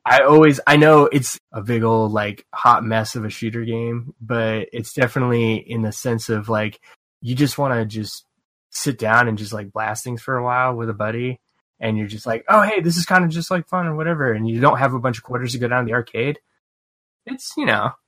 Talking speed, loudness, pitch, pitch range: 240 wpm, -19 LUFS, 120 Hz, 110-145 Hz